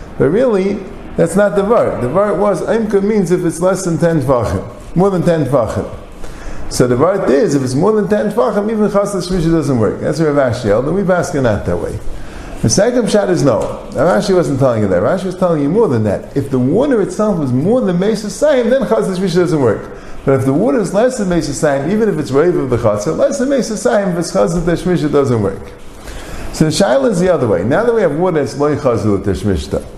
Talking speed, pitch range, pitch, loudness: 230 wpm, 140-205 Hz, 180 Hz, -14 LUFS